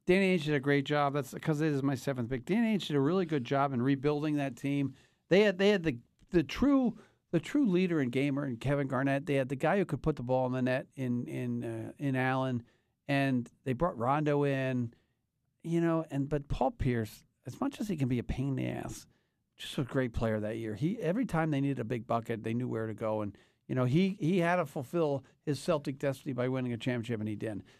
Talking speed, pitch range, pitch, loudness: 250 wpm, 125-160 Hz, 140 Hz, -32 LUFS